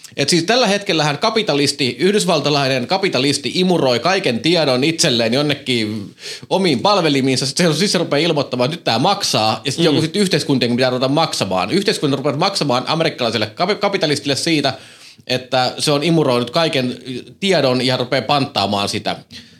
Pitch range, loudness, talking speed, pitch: 125-165 Hz, -16 LUFS, 140 wpm, 145 Hz